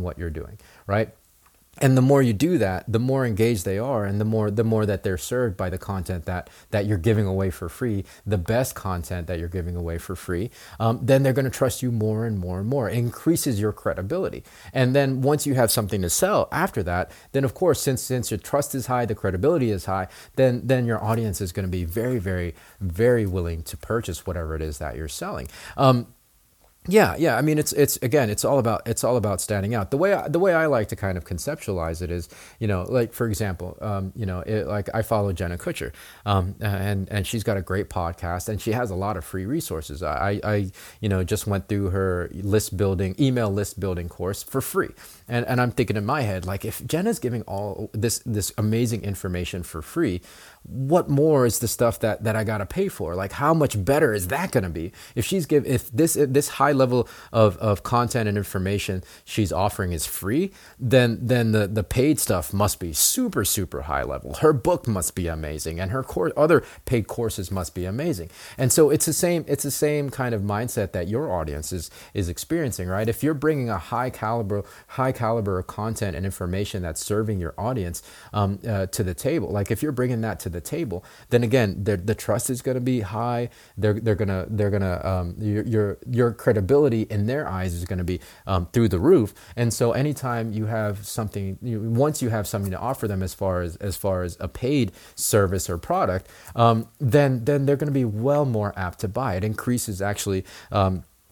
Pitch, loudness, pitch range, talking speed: 105 Hz, -24 LUFS, 95-125 Hz, 220 wpm